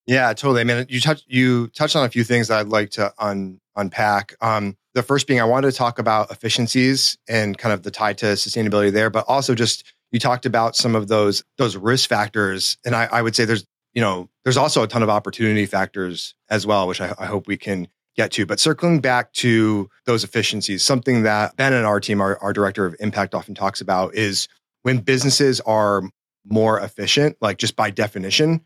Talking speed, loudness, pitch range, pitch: 215 wpm, -19 LUFS, 100-125 Hz, 110 Hz